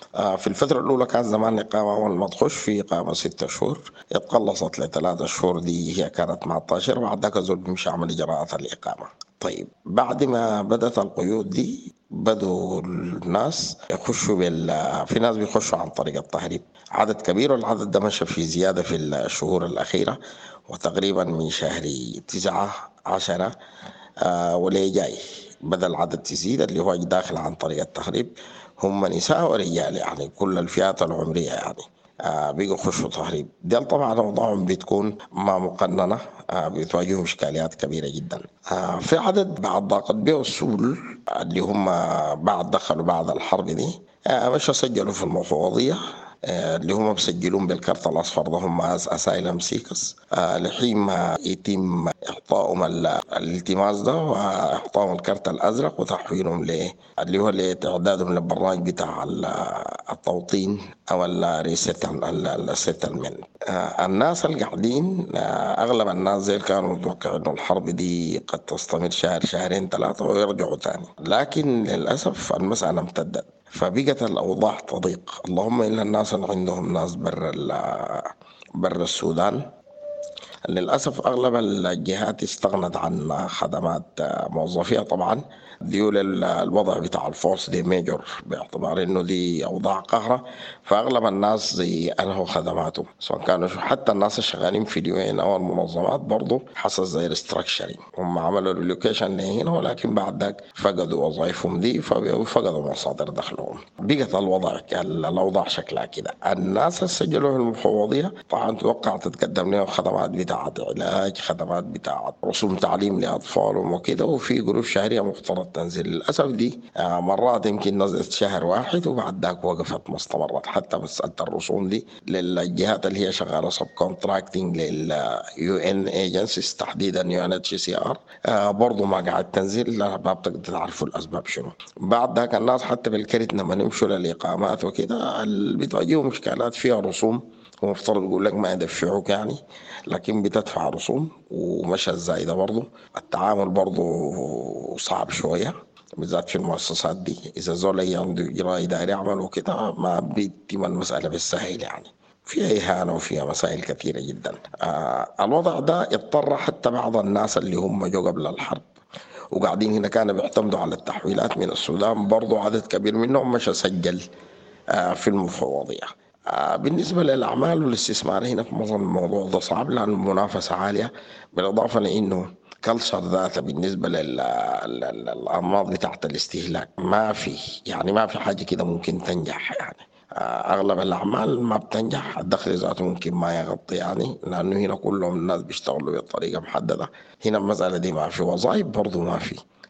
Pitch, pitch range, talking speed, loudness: 100 Hz, 90-110 Hz, 130 wpm, -24 LUFS